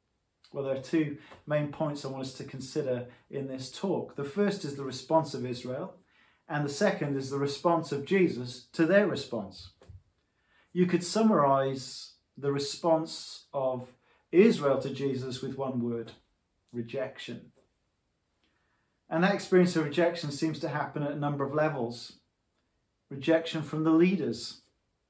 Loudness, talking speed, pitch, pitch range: -30 LUFS, 150 wpm, 140 Hz, 125-160 Hz